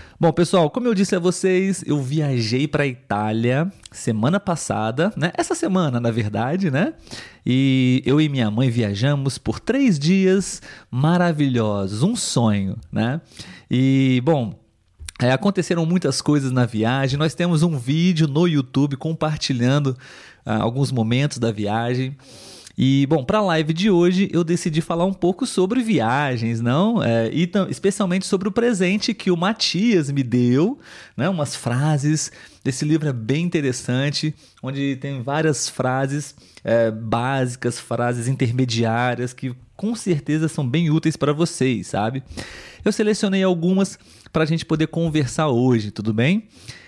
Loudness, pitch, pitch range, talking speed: -20 LUFS, 145 Hz, 125-175 Hz, 145 wpm